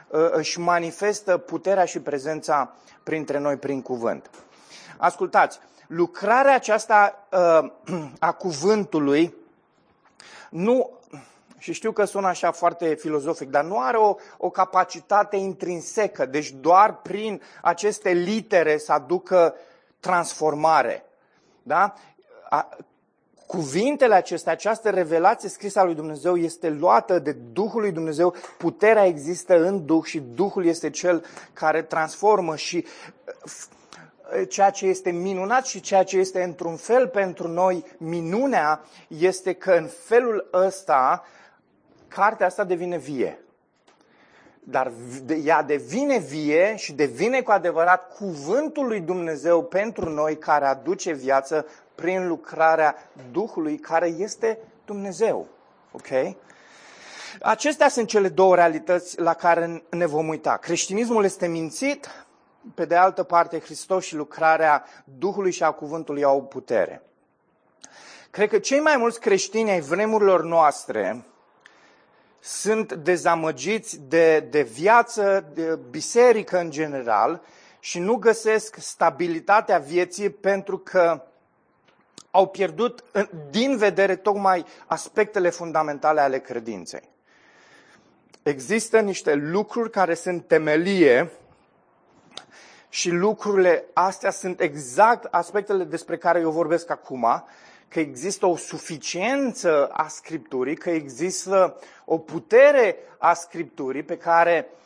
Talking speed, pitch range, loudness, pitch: 115 wpm, 160-200 Hz, -22 LUFS, 175 Hz